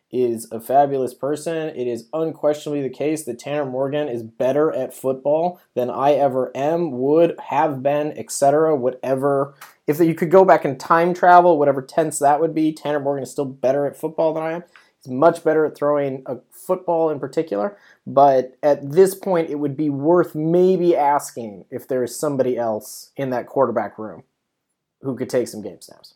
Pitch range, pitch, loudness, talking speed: 130-160 Hz, 145 Hz, -19 LUFS, 190 wpm